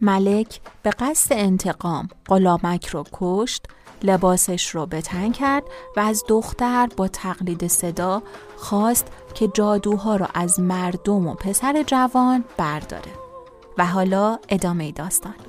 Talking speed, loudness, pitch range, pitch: 120 wpm, -21 LUFS, 180-230 Hz, 195 Hz